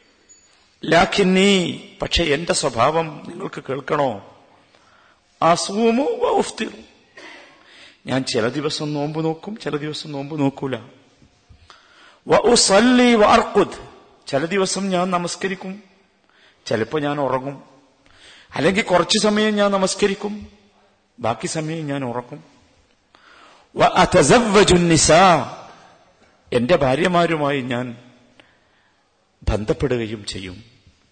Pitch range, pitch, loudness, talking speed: 135-195 Hz, 160 Hz, -18 LUFS, 75 wpm